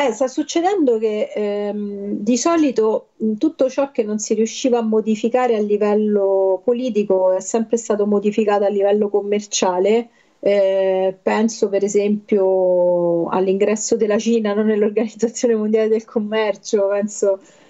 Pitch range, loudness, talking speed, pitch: 200-230 Hz, -18 LUFS, 130 wpm, 215 Hz